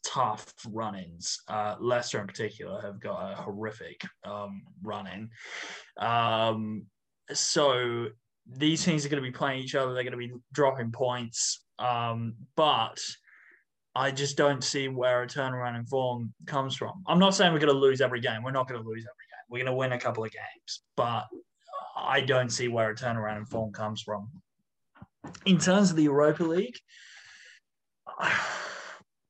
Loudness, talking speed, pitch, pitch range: -29 LUFS, 175 wpm, 125 Hz, 110-140 Hz